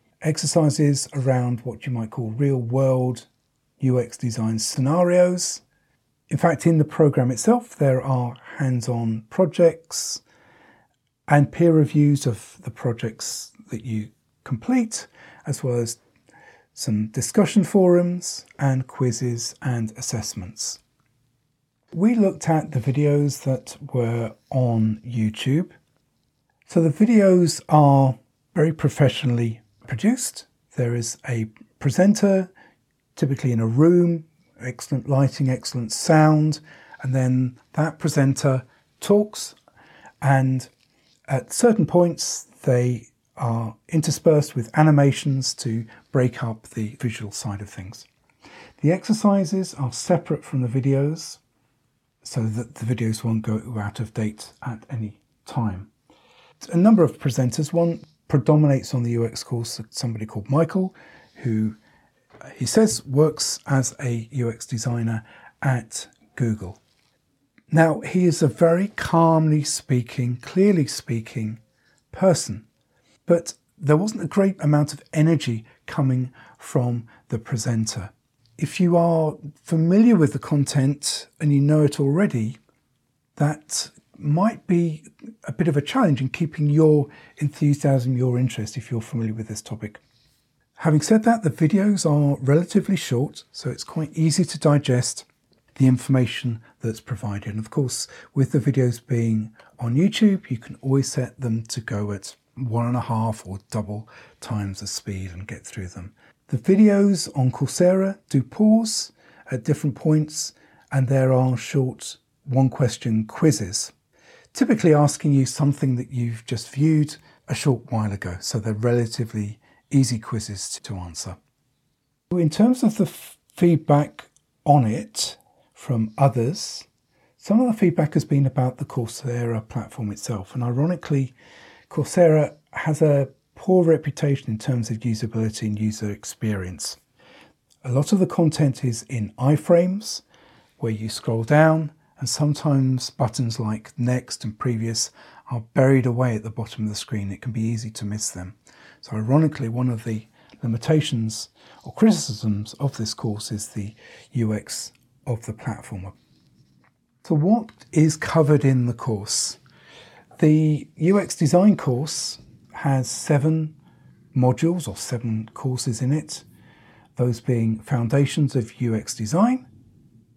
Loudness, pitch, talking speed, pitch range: -22 LUFS, 130 Hz, 135 wpm, 115-155 Hz